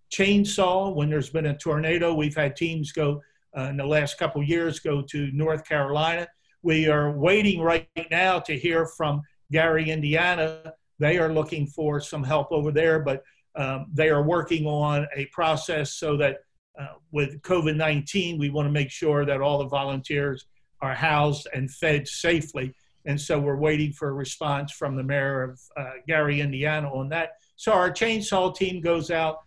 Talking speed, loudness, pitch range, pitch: 180 wpm, -25 LUFS, 145-165 Hz, 150 Hz